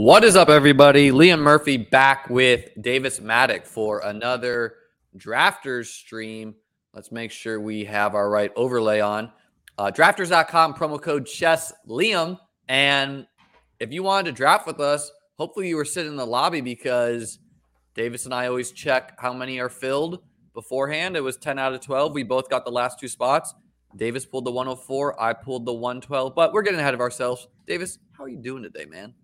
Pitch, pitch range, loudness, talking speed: 130 Hz, 120-150 Hz, -21 LUFS, 185 wpm